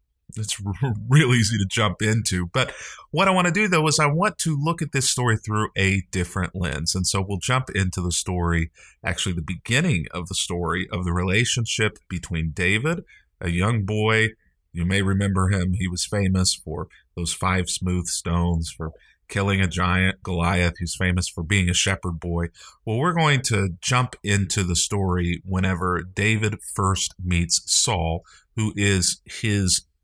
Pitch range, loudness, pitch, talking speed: 90-110 Hz, -22 LUFS, 95 Hz, 170 wpm